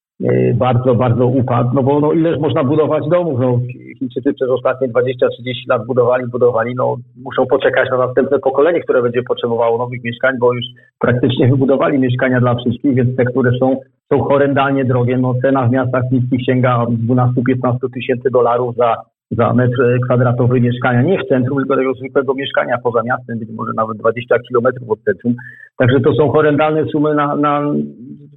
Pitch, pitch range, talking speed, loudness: 125 Hz, 120-135 Hz, 170 wpm, -15 LUFS